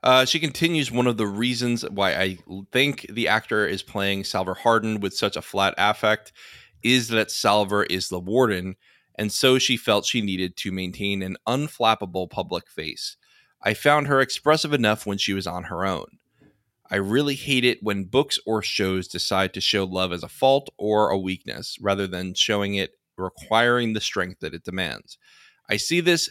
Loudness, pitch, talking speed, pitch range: -23 LUFS, 105 Hz, 185 wpm, 95-125 Hz